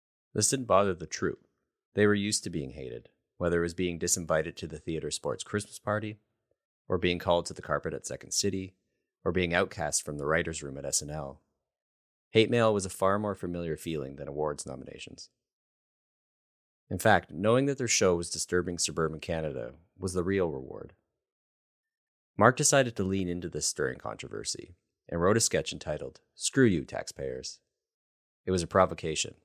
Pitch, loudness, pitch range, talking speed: 90 Hz, -29 LUFS, 80-105 Hz, 175 wpm